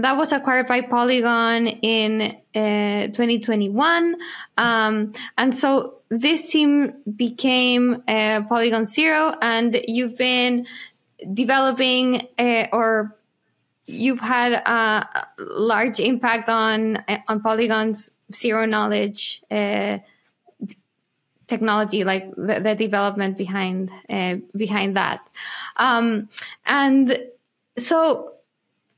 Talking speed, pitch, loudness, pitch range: 95 wpm, 230 Hz, -20 LUFS, 215-255 Hz